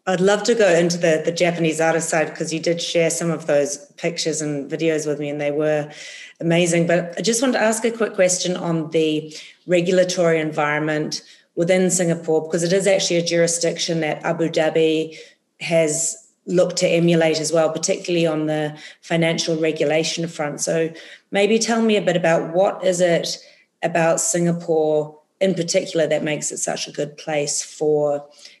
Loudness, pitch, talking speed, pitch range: -20 LUFS, 165 Hz, 175 wpm, 155-180 Hz